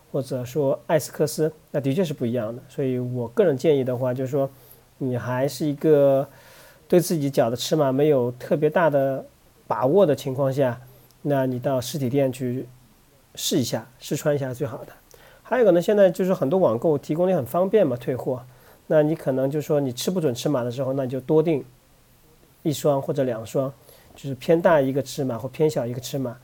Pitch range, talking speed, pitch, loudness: 130-155 Hz, 300 characters per minute, 140 Hz, -23 LUFS